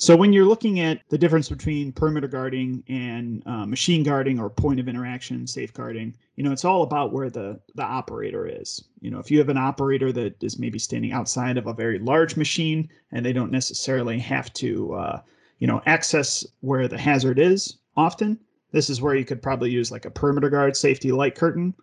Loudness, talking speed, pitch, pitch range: -23 LUFS, 205 wpm, 140 Hz, 125-160 Hz